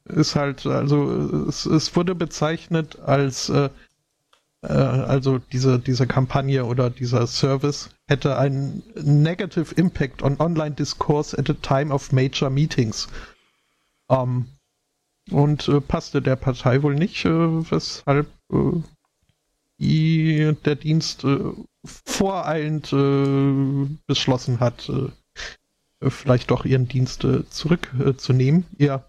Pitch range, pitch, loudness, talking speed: 135-155 Hz, 140 Hz, -21 LUFS, 120 wpm